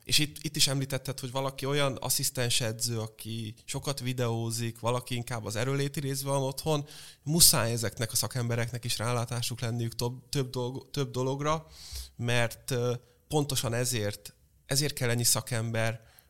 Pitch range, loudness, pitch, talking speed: 115-135 Hz, -29 LUFS, 125 Hz, 145 wpm